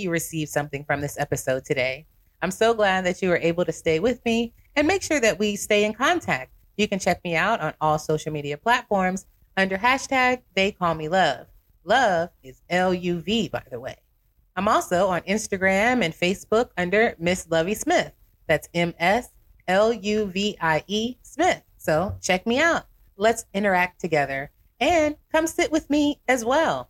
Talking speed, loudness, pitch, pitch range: 165 wpm, -23 LUFS, 195 Hz, 165-235 Hz